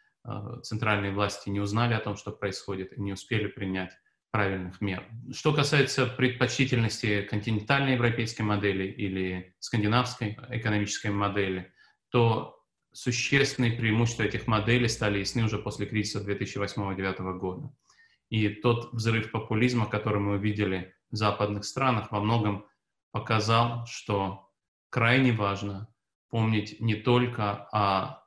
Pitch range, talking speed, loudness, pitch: 100-120 Hz, 120 wpm, -28 LUFS, 105 Hz